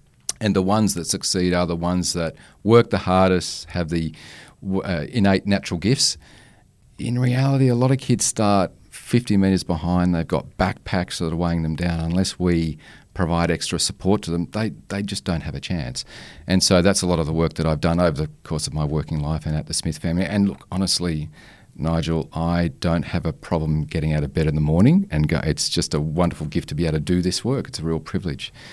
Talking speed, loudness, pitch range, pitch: 225 wpm, -21 LUFS, 80-95 Hz, 85 Hz